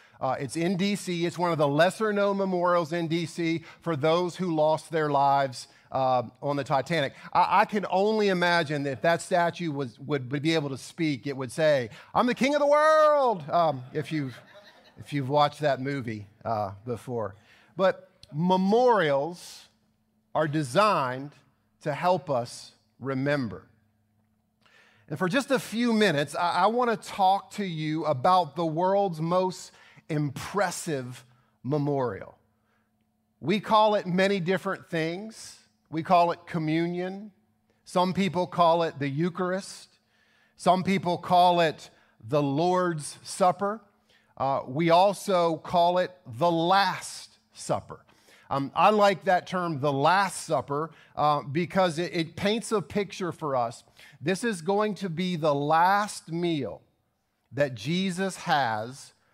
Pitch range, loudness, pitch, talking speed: 140-185 Hz, -26 LUFS, 165 Hz, 145 wpm